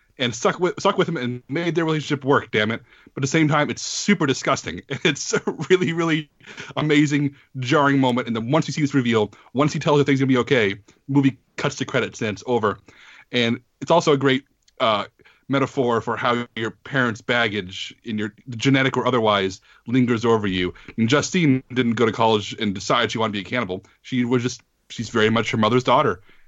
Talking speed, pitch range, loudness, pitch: 215 wpm, 115-145 Hz, -21 LUFS, 130 Hz